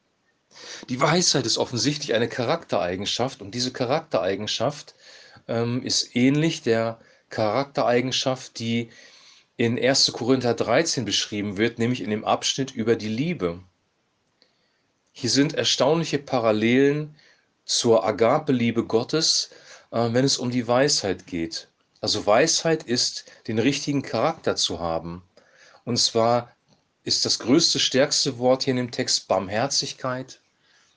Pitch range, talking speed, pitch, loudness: 115-140 Hz, 120 wpm, 125 Hz, -23 LUFS